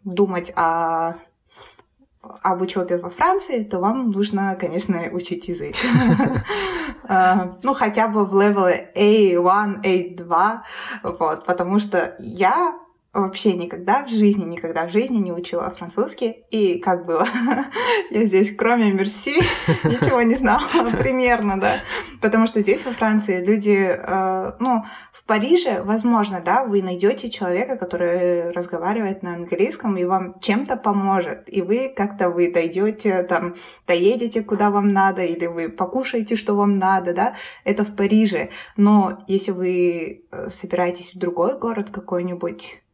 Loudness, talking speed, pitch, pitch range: -20 LUFS, 135 wpm, 195 Hz, 180-220 Hz